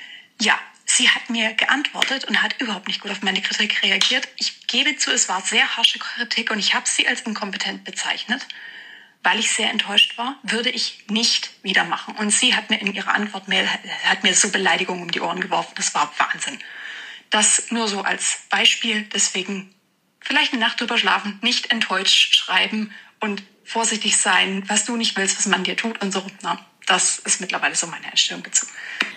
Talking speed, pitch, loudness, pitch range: 190 wpm, 215 Hz, -19 LUFS, 195-235 Hz